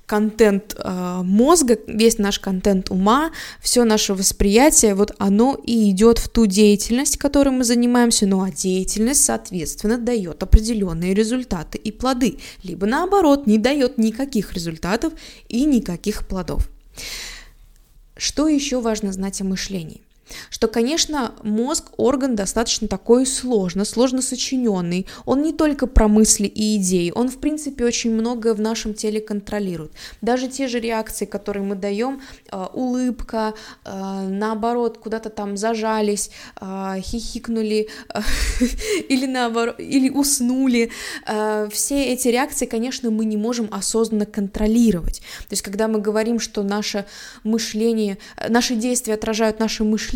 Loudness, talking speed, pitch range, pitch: -20 LUFS, 135 wpm, 205-245 Hz, 220 Hz